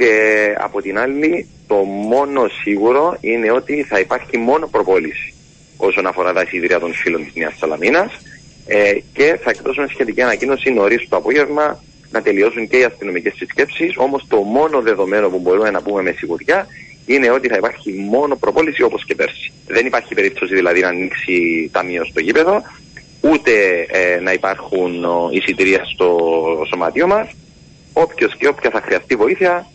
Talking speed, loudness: 160 wpm, -15 LUFS